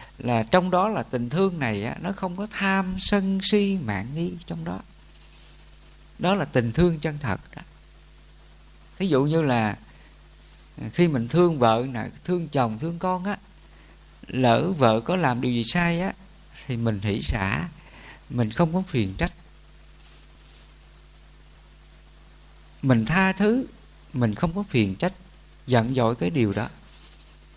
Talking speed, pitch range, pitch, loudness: 150 wpm, 120-185 Hz, 160 Hz, -24 LUFS